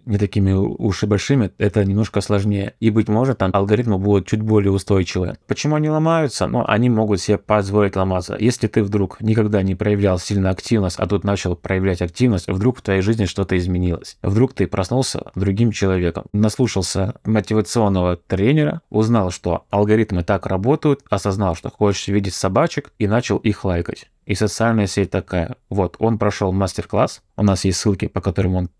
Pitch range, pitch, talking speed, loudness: 95-110 Hz, 105 Hz, 175 wpm, -19 LUFS